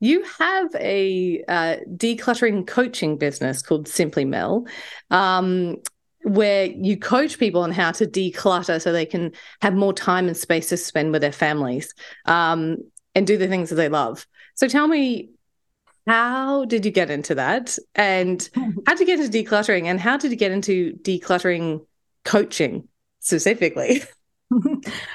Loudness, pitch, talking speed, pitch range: -21 LUFS, 190 Hz, 155 wpm, 170-235 Hz